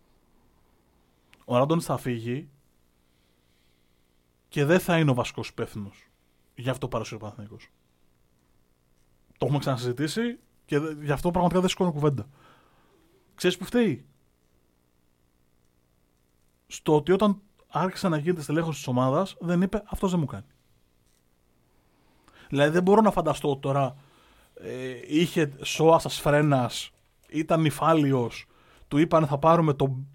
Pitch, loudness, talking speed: 130 Hz, -25 LUFS, 125 wpm